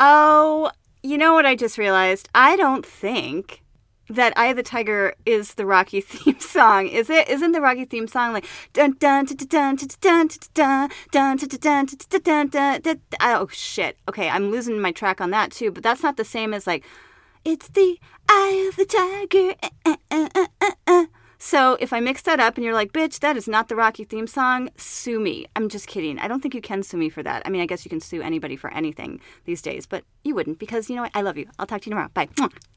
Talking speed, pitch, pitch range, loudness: 220 wpm, 260 Hz, 215-315 Hz, -20 LUFS